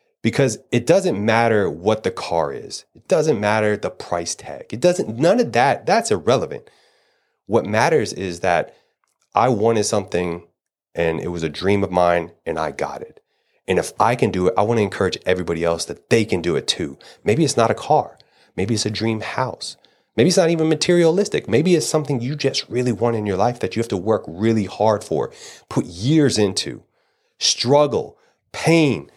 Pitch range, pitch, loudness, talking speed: 95-150 Hz, 115 Hz, -19 LUFS, 195 wpm